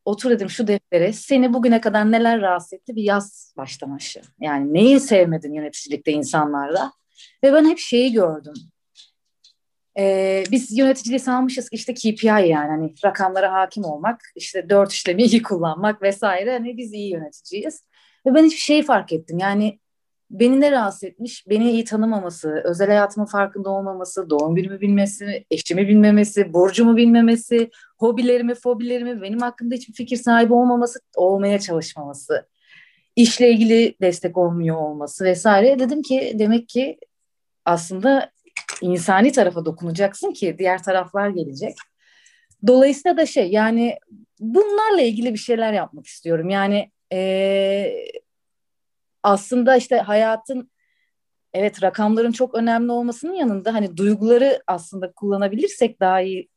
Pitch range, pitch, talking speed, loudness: 185-240 Hz, 210 Hz, 130 wpm, -19 LUFS